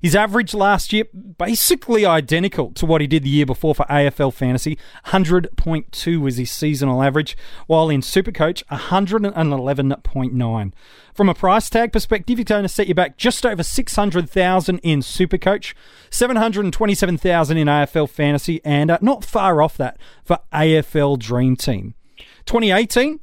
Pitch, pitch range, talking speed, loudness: 170 Hz, 145-205 Hz, 140 wpm, -18 LUFS